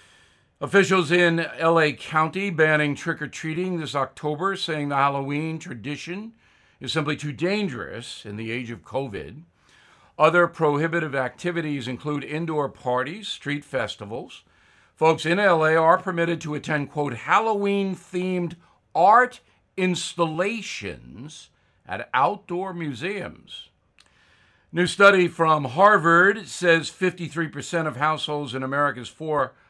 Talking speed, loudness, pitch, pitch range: 115 wpm, -23 LUFS, 160 Hz, 145-180 Hz